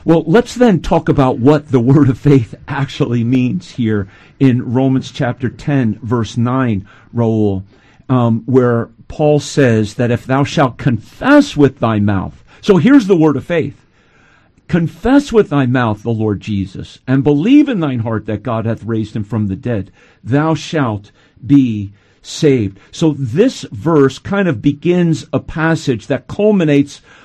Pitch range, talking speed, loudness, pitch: 115-155 Hz, 160 wpm, -14 LUFS, 135 Hz